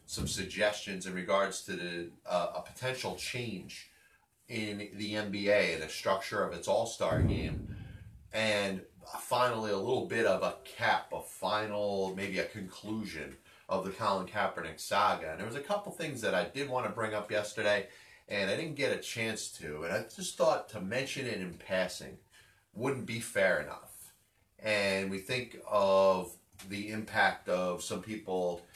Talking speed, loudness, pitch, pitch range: 170 wpm, -33 LUFS, 105 Hz, 95-110 Hz